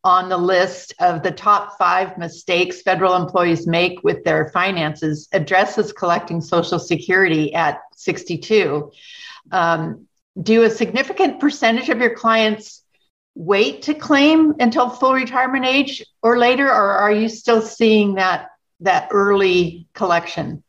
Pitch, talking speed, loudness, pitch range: 195 Hz, 135 wpm, -17 LUFS, 175-230 Hz